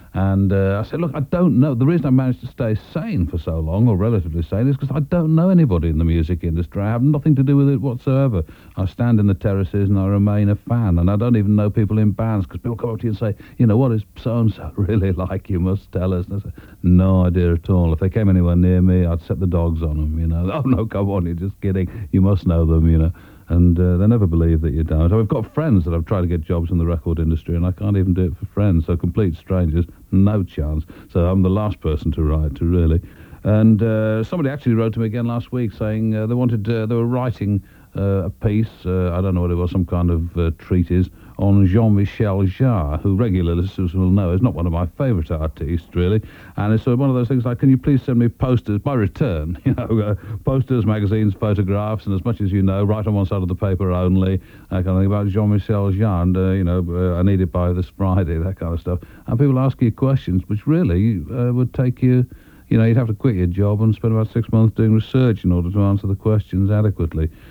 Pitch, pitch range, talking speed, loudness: 100 Hz, 90-115 Hz, 265 wpm, -19 LUFS